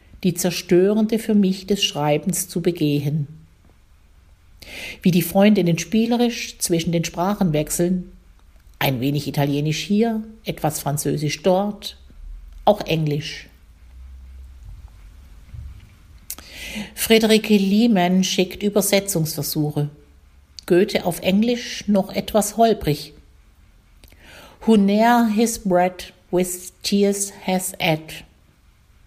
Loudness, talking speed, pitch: -20 LUFS, 90 wpm, 165 Hz